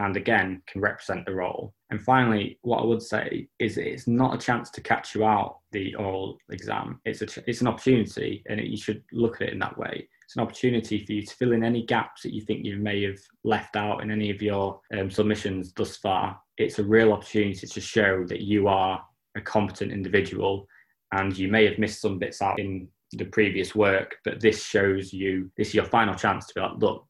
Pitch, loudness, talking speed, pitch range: 105 Hz, -26 LUFS, 230 wpm, 100-110 Hz